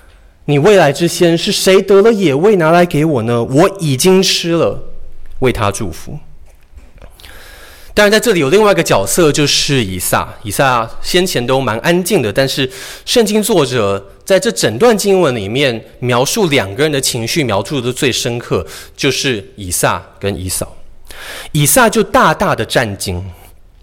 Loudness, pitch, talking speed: -12 LUFS, 135 Hz, 235 characters per minute